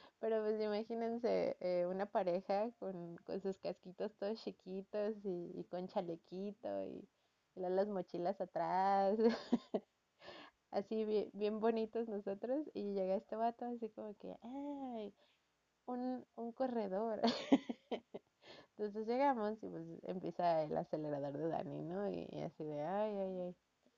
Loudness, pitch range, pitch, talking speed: -41 LUFS, 185-225 Hz, 205 Hz, 140 wpm